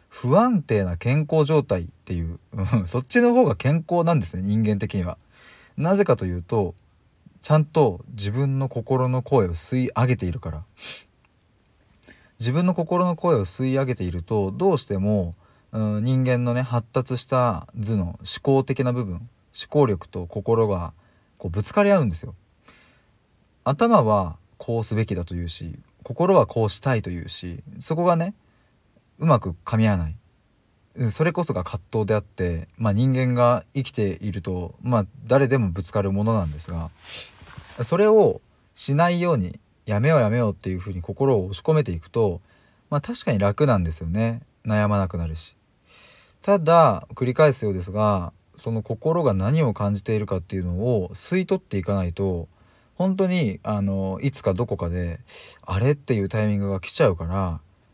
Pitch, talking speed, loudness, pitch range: 110 Hz, 320 characters per minute, -23 LUFS, 95-130 Hz